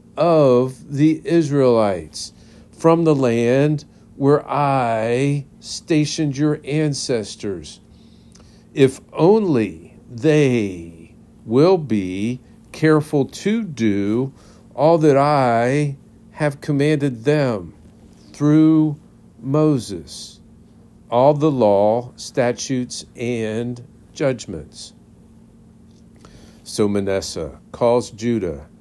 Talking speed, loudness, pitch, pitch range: 75 wpm, -18 LUFS, 130 Hz, 115-150 Hz